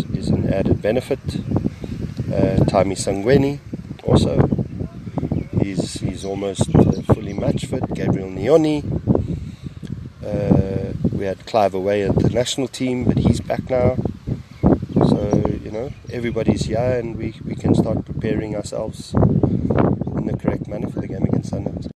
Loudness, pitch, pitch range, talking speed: -20 LUFS, 115 Hz, 105-130 Hz, 140 wpm